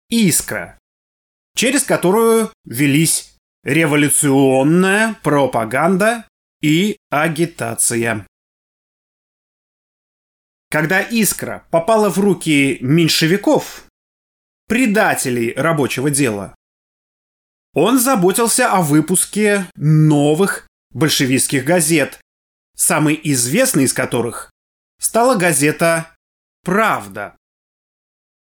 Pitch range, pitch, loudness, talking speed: 130-190 Hz, 155 Hz, -15 LUFS, 65 wpm